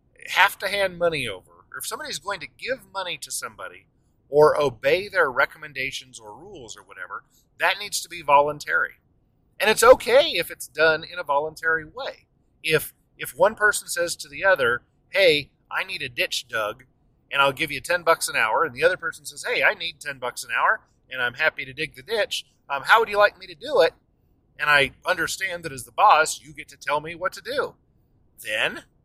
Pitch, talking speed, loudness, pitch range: 160 Hz, 215 wpm, -22 LUFS, 145-205 Hz